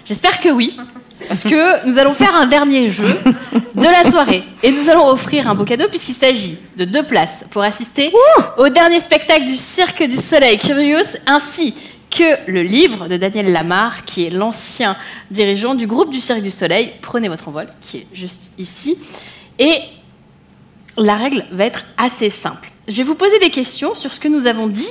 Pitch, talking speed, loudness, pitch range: 250 Hz, 190 wpm, -13 LUFS, 205-300 Hz